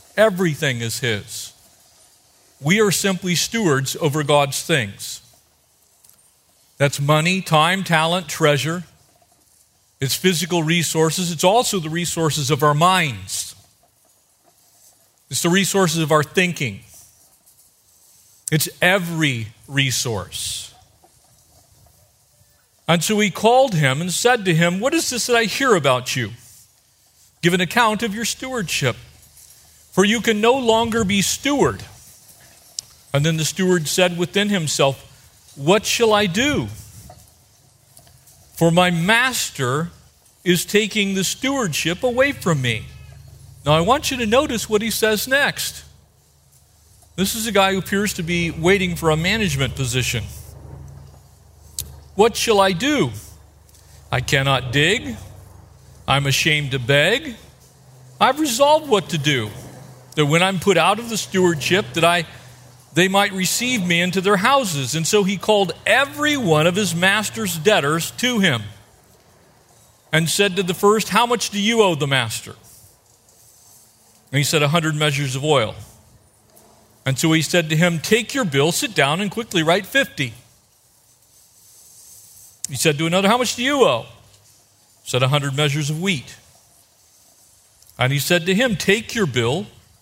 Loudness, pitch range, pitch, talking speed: -18 LUFS, 120-195 Hz, 155 Hz, 140 wpm